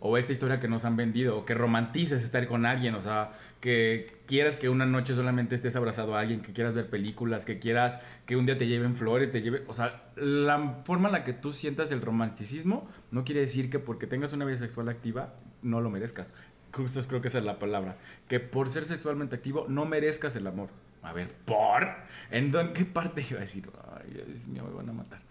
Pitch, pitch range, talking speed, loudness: 120 Hz, 115-135 Hz, 225 wpm, -30 LUFS